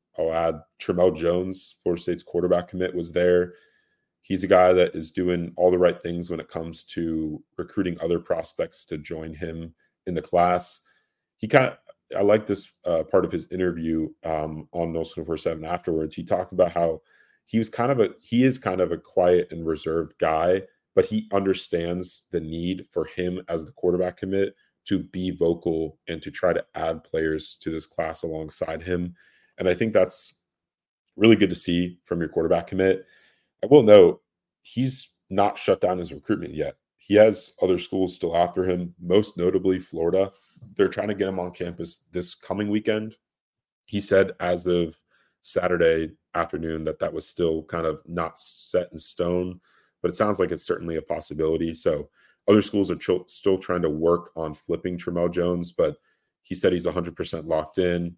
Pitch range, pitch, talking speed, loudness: 80-95 Hz, 90 Hz, 185 wpm, -24 LUFS